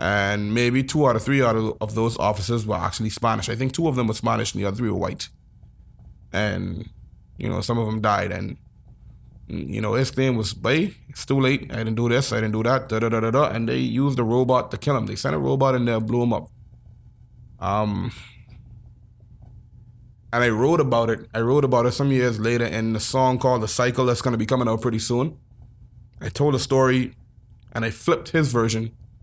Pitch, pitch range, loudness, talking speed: 115 Hz, 110-125 Hz, -22 LUFS, 225 wpm